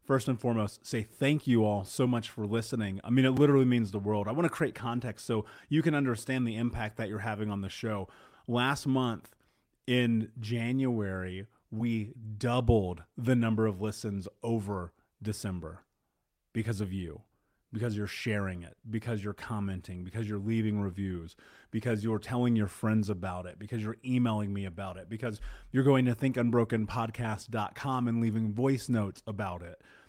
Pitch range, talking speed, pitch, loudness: 105-120 Hz, 170 wpm, 110 Hz, -32 LUFS